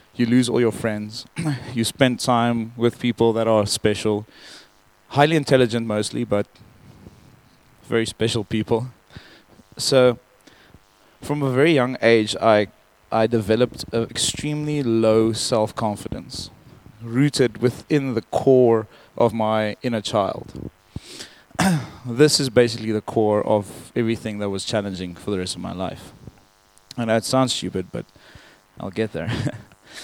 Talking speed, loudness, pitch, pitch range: 130 wpm, -21 LUFS, 115 Hz, 105-125 Hz